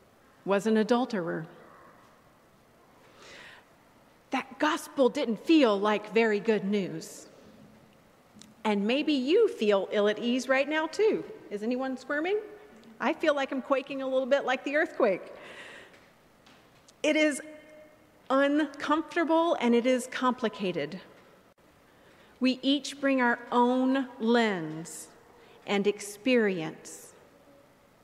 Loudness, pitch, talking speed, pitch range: -28 LUFS, 260 Hz, 105 wpm, 220-305 Hz